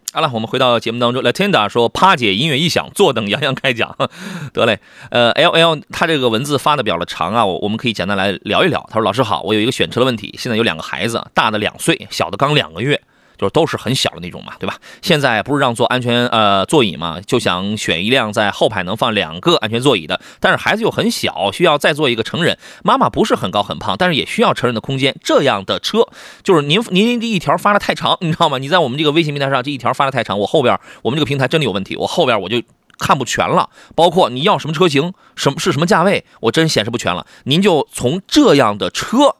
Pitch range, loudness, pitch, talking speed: 115-165 Hz, -15 LUFS, 135 Hz, 385 characters per minute